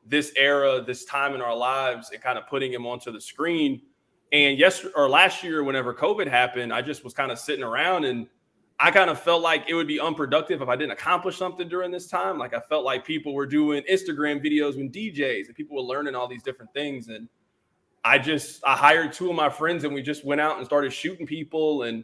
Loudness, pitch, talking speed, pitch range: -24 LUFS, 145 Hz, 235 wpm, 130-160 Hz